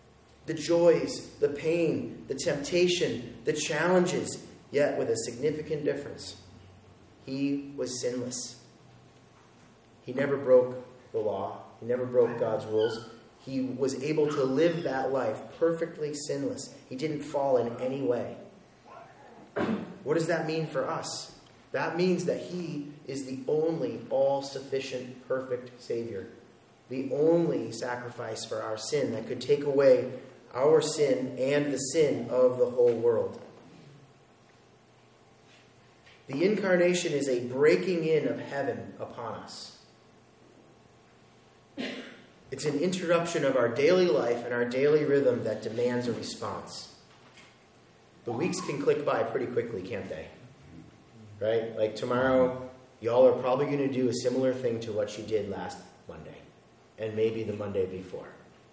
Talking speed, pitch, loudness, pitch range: 135 wpm, 140 Hz, -29 LUFS, 125-170 Hz